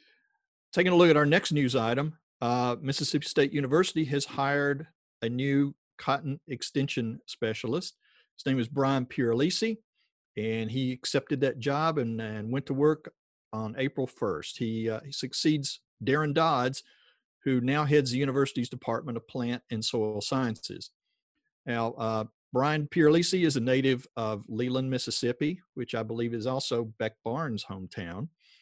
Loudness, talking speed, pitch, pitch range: -29 LUFS, 150 wpm, 130 Hz, 115-150 Hz